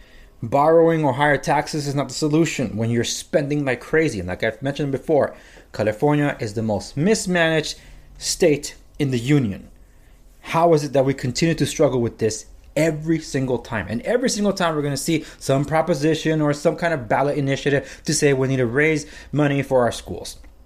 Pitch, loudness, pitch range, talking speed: 145 Hz, -21 LUFS, 125-160 Hz, 190 wpm